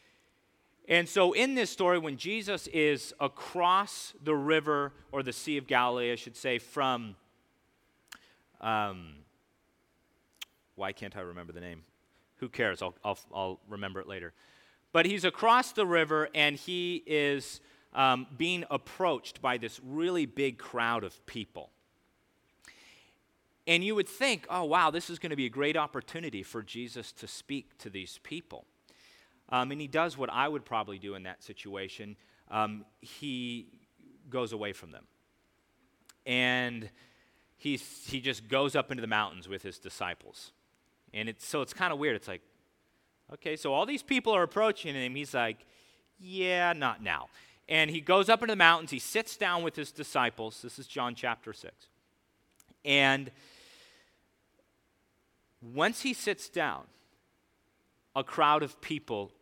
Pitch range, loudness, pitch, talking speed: 115-165 Hz, -31 LUFS, 135 Hz, 155 wpm